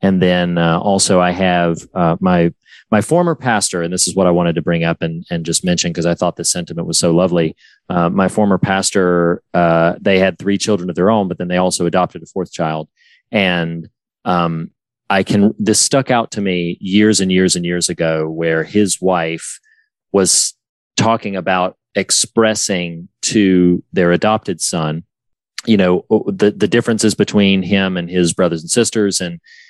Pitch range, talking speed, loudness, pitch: 85-100 Hz, 185 wpm, -15 LUFS, 90 Hz